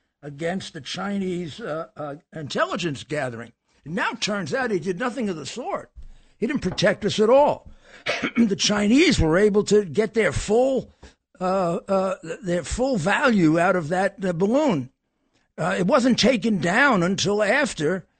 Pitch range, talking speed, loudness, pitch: 175-230 Hz, 165 wpm, -22 LUFS, 195 Hz